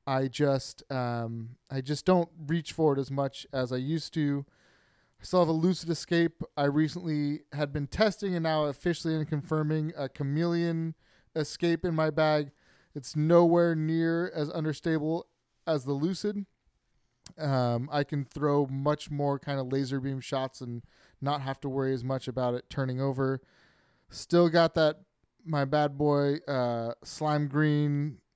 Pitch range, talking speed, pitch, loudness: 135-160 Hz, 160 wpm, 150 Hz, -29 LUFS